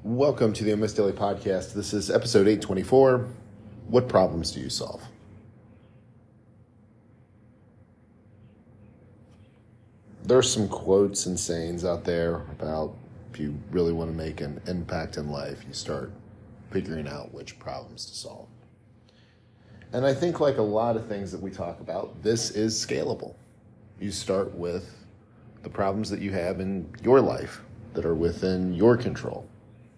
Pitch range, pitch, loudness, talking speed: 95-115 Hz, 105 Hz, -26 LUFS, 145 wpm